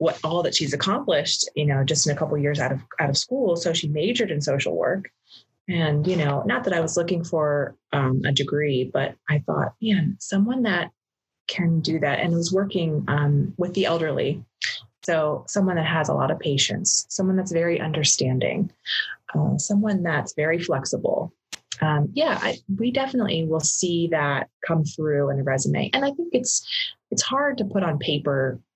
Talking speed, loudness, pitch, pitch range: 195 wpm, -23 LUFS, 160 Hz, 145-185 Hz